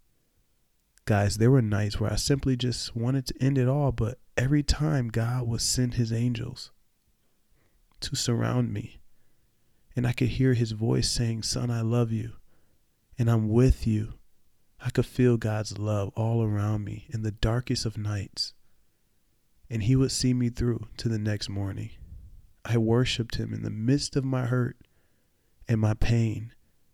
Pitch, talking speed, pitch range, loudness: 115 Hz, 165 wpm, 110-125 Hz, -27 LUFS